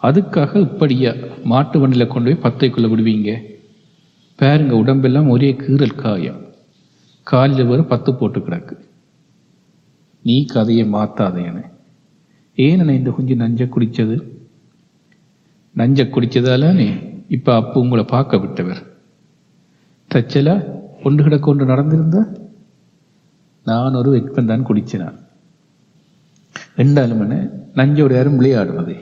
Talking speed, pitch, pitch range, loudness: 95 wpm, 130 Hz, 120-145 Hz, -15 LUFS